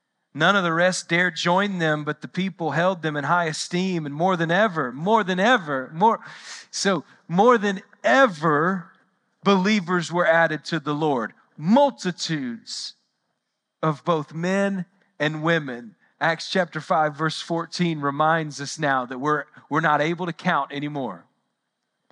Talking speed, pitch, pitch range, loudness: 150 wpm, 170 Hz, 155-190 Hz, -22 LUFS